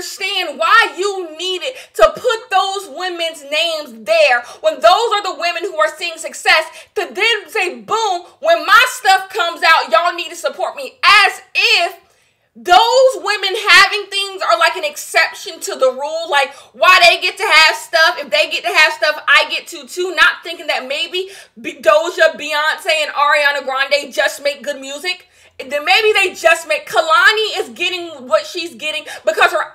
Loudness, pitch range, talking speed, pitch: -13 LUFS, 310-385 Hz, 180 wpm, 335 Hz